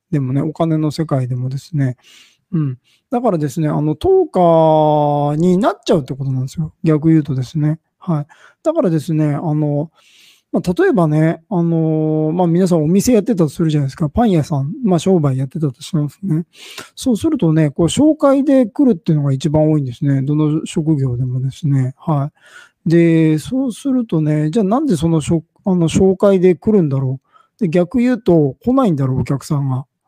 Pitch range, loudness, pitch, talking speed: 145-185 Hz, -16 LUFS, 160 Hz, 360 characters per minute